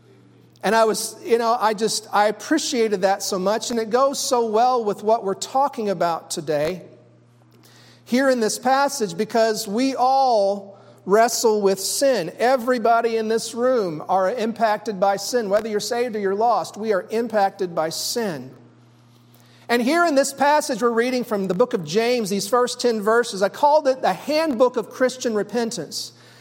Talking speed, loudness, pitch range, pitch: 175 wpm, -21 LUFS, 195-245 Hz, 225 Hz